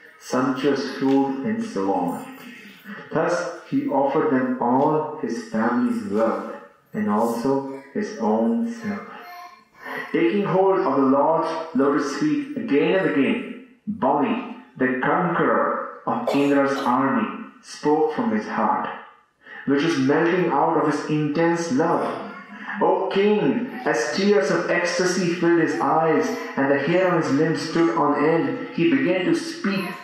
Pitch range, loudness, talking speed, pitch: 150-230 Hz, -22 LUFS, 135 wpm, 175 Hz